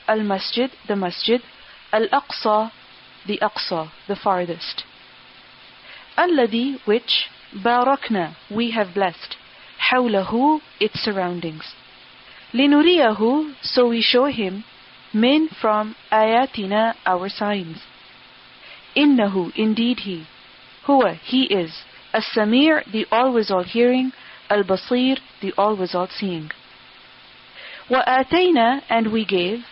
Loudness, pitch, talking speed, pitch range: -20 LUFS, 220 Hz, 105 wpm, 195-255 Hz